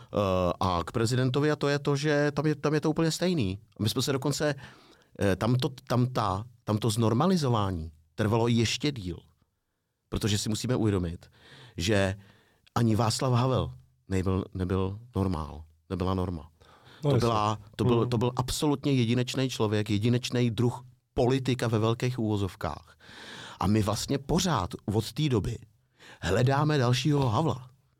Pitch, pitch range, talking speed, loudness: 115 Hz, 100-130 Hz, 145 wpm, -28 LUFS